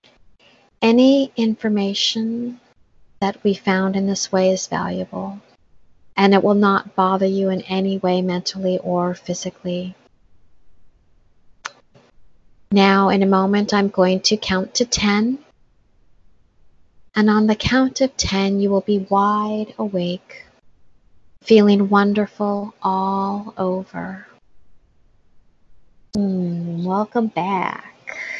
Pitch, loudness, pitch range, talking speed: 195 Hz, -19 LUFS, 185-210 Hz, 105 wpm